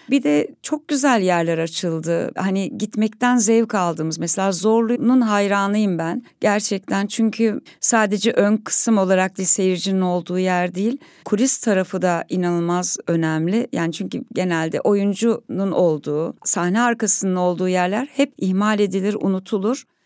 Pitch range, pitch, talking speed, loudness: 180-225 Hz, 195 Hz, 130 wpm, -19 LUFS